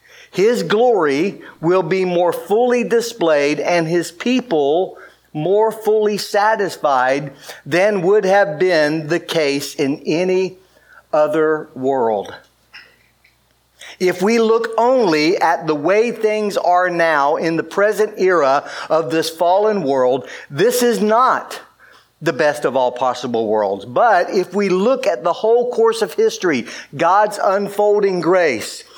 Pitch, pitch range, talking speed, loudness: 185 Hz, 160-220 Hz, 130 wpm, -16 LUFS